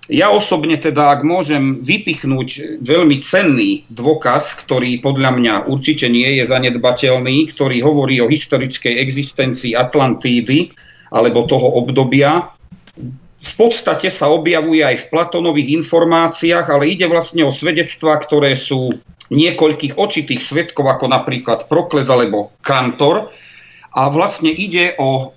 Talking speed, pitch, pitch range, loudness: 125 wpm, 145 Hz, 130-165 Hz, -14 LUFS